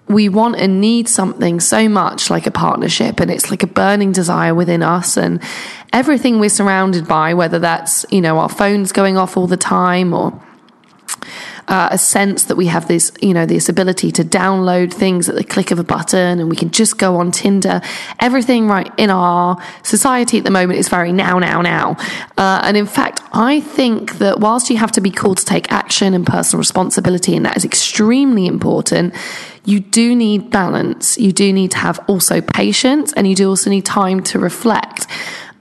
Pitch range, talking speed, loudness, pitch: 180-215 Hz, 200 wpm, -13 LUFS, 195 Hz